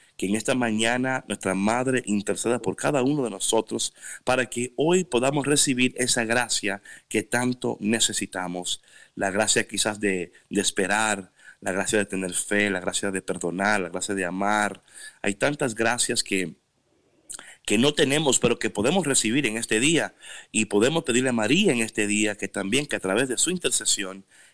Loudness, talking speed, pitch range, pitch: -24 LUFS, 175 wpm, 100-125 Hz, 110 Hz